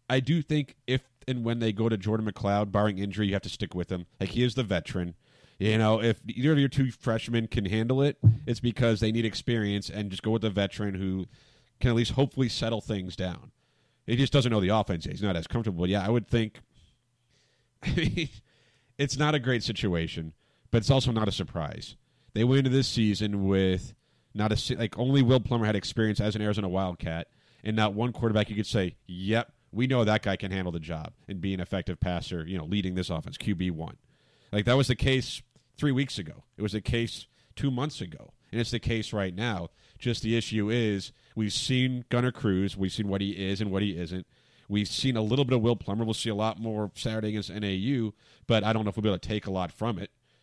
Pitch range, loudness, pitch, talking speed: 100-120 Hz, -29 LUFS, 110 Hz, 230 wpm